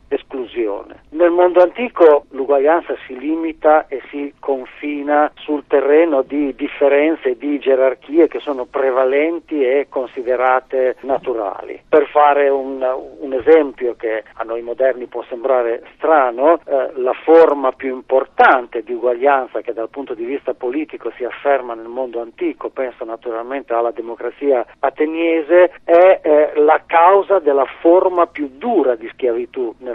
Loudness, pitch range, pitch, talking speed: -16 LUFS, 130-165 Hz, 140 Hz, 140 wpm